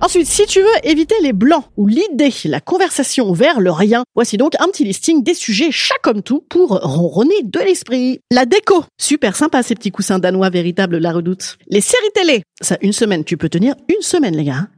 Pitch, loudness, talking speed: 255 Hz, -14 LUFS, 210 wpm